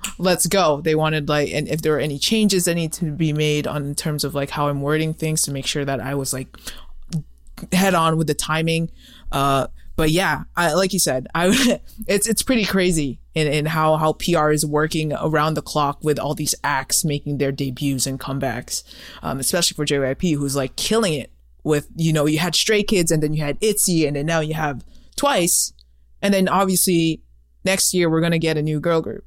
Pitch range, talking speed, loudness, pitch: 140-170 Hz, 220 wpm, -20 LUFS, 155 Hz